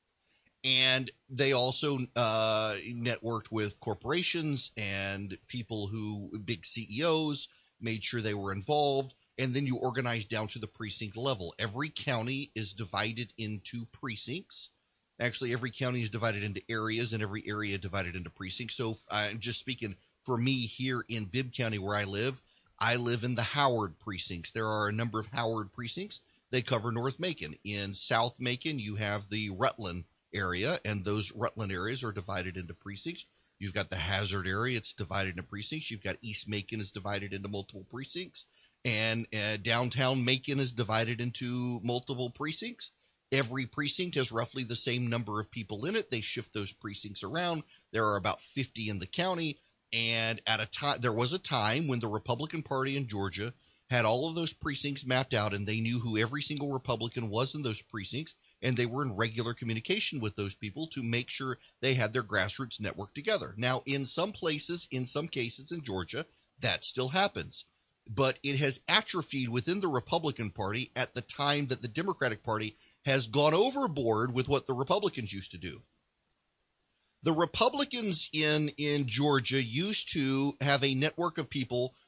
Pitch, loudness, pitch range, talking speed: 120 Hz, -31 LUFS, 105-135 Hz, 175 wpm